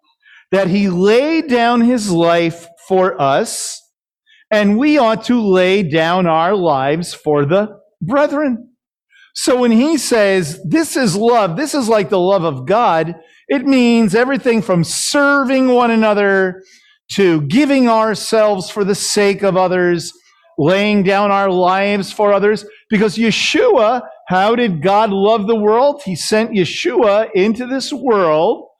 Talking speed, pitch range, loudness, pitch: 140 wpm, 185-245 Hz, -14 LUFS, 210 Hz